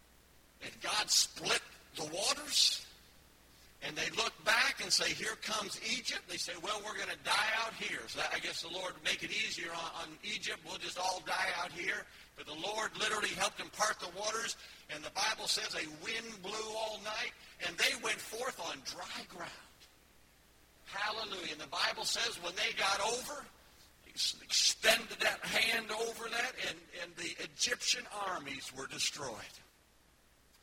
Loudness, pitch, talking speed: -35 LUFS, 185 Hz, 165 wpm